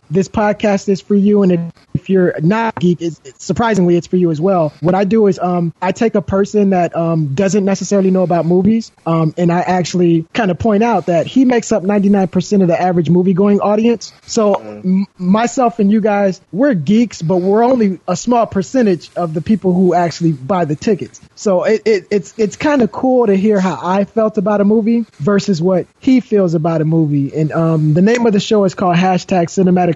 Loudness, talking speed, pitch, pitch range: -14 LUFS, 220 wpm, 190 Hz, 175-210 Hz